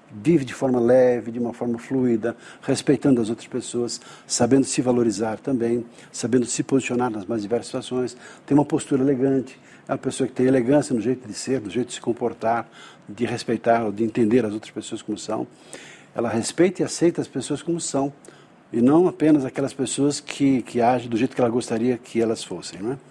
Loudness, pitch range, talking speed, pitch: -23 LUFS, 115-135 Hz, 200 wpm, 125 Hz